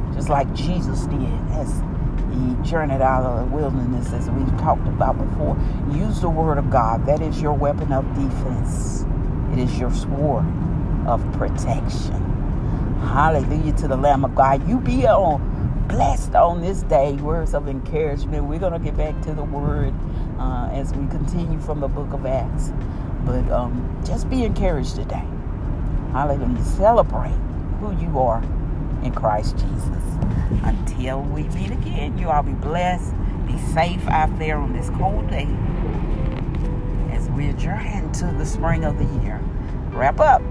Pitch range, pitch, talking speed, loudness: 85-135 Hz, 125 Hz, 155 wpm, -22 LUFS